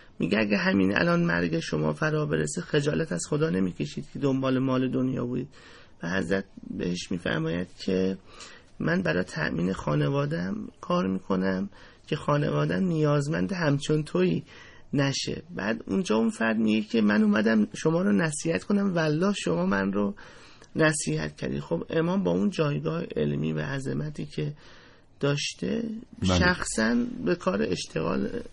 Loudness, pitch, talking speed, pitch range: -27 LUFS, 125 Hz, 140 wpm, 95-160 Hz